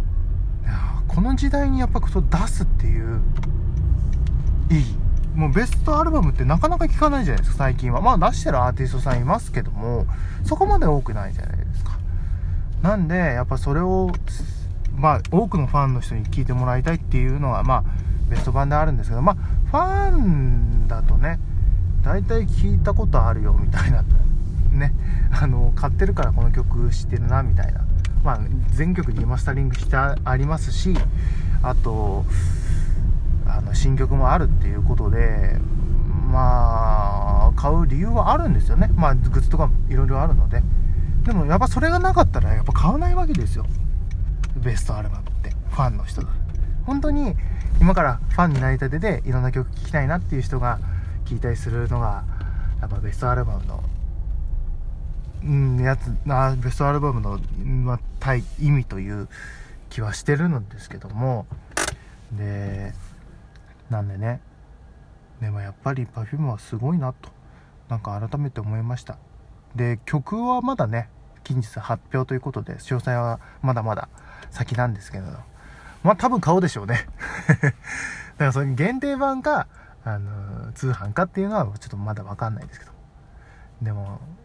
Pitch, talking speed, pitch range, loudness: 110 Hz, 335 characters per minute, 90-130 Hz, -22 LUFS